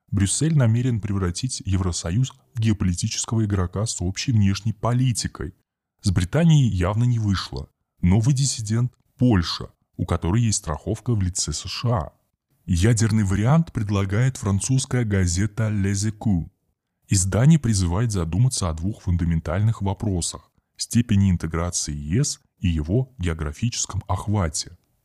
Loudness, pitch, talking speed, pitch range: -23 LUFS, 105 Hz, 115 wpm, 90-120 Hz